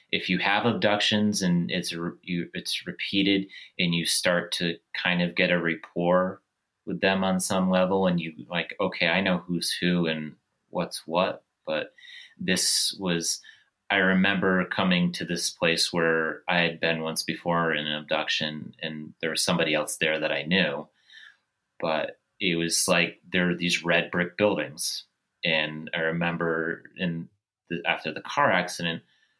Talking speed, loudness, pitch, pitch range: 165 wpm, -25 LUFS, 85 Hz, 85-95 Hz